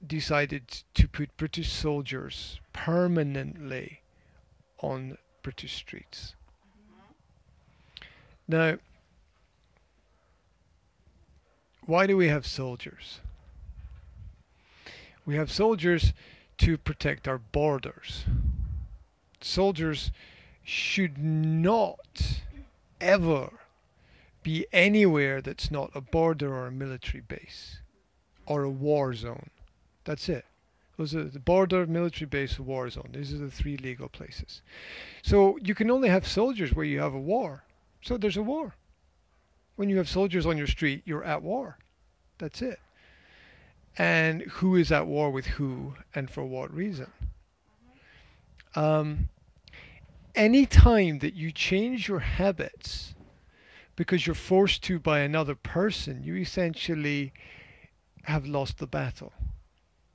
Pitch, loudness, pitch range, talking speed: 145 Hz, -28 LUFS, 105-175 Hz, 115 wpm